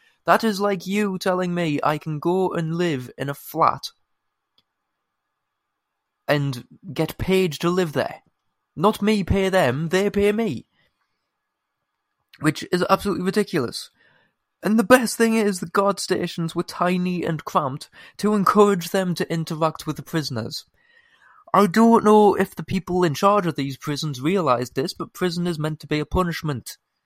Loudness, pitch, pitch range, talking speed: -21 LUFS, 180 Hz, 155-200 Hz, 160 wpm